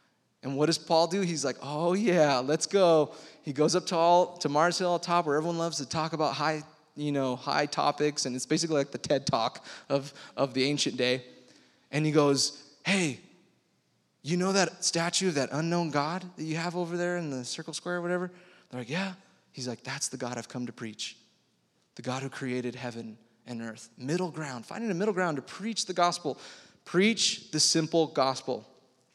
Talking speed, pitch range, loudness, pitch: 205 wpm, 130-175 Hz, -29 LUFS, 155 Hz